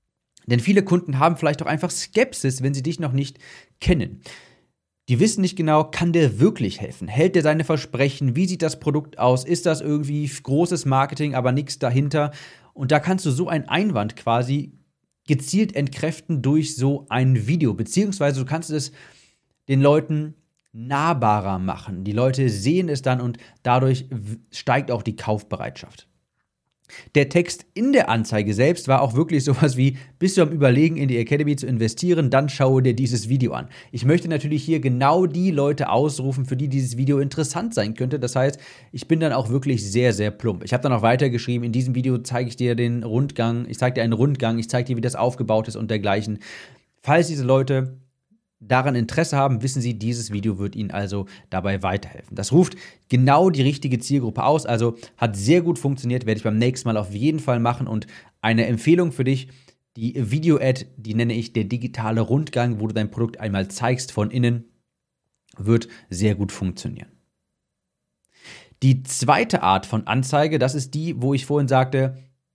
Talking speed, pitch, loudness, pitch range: 185 wpm, 130 Hz, -21 LUFS, 115-150 Hz